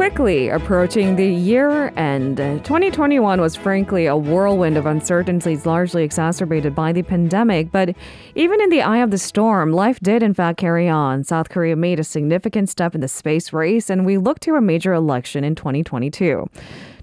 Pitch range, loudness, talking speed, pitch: 160-205 Hz, -18 LUFS, 175 wpm, 175 Hz